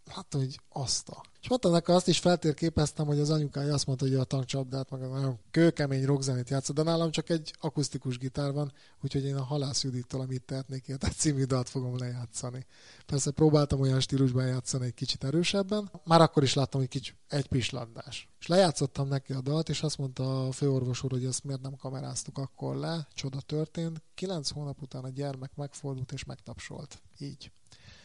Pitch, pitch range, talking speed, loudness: 140 Hz, 130-150 Hz, 185 wpm, -30 LUFS